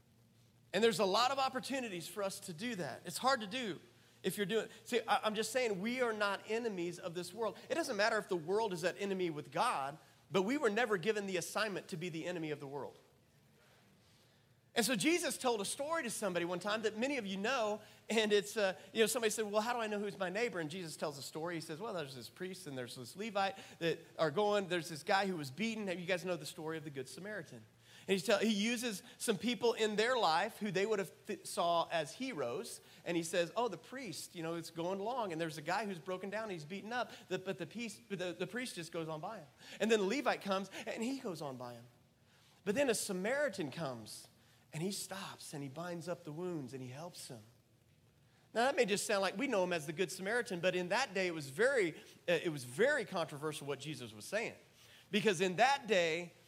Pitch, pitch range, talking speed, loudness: 190 Hz, 160-220 Hz, 245 wpm, -37 LUFS